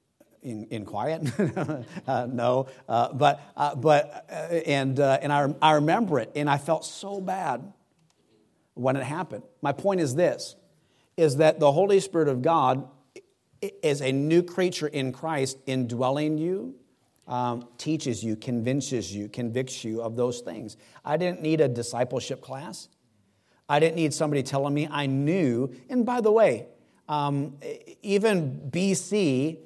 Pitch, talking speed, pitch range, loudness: 145 Hz, 150 wpm, 130-165 Hz, -26 LUFS